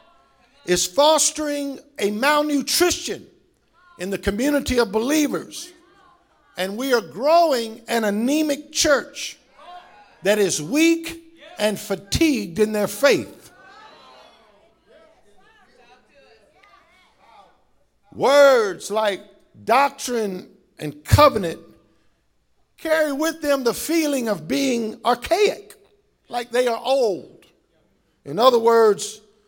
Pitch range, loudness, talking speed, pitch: 215-310 Hz, -20 LUFS, 90 wpm, 270 Hz